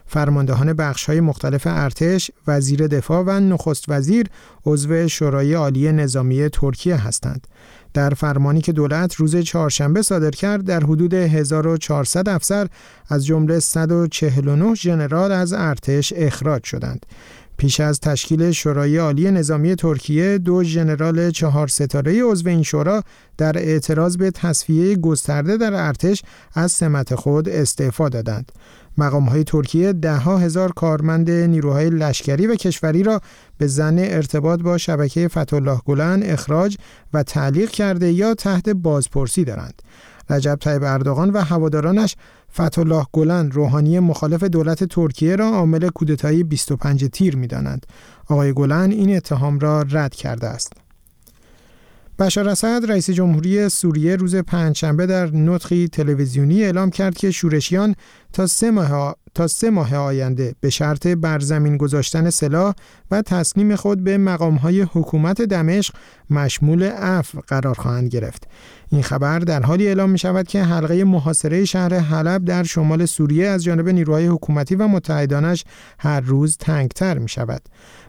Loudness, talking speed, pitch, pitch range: -18 LUFS, 135 wpm, 160 Hz, 145-180 Hz